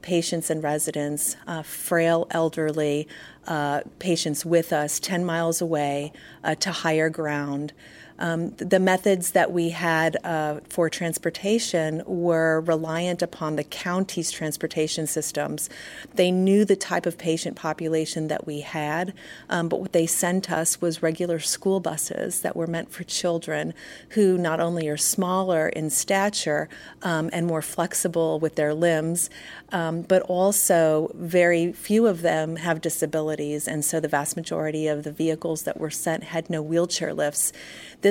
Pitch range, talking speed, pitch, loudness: 155-175 Hz, 155 wpm, 165 Hz, -24 LUFS